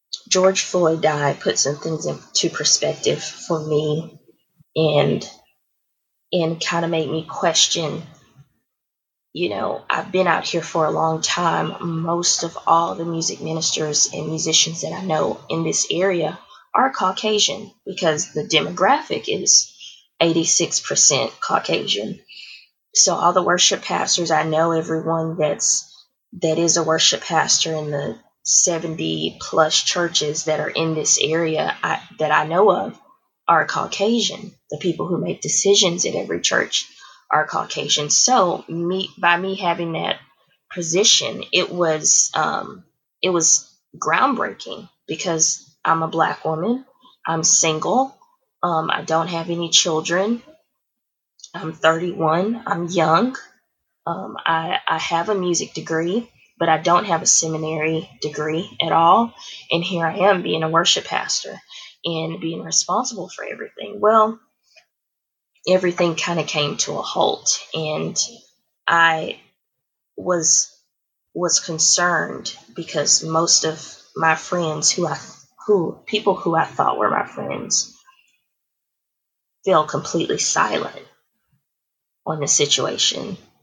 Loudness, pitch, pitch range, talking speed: -19 LUFS, 165 Hz, 160-185 Hz, 135 wpm